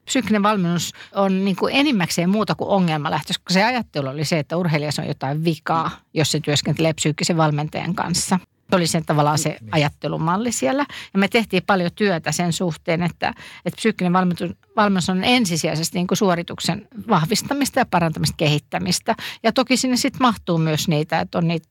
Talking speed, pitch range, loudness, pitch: 170 wpm, 160-205 Hz, -20 LUFS, 175 Hz